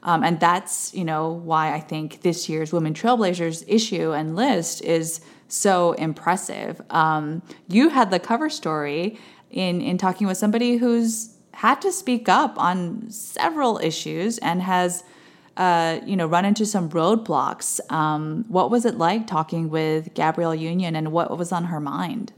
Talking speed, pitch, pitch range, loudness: 165 wpm, 175 Hz, 160-215 Hz, -22 LUFS